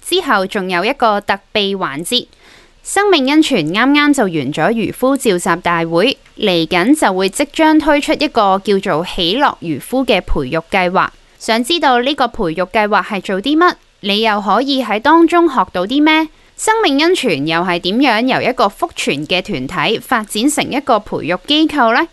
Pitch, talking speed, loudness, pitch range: 230 Hz, 260 characters per minute, -14 LUFS, 185-290 Hz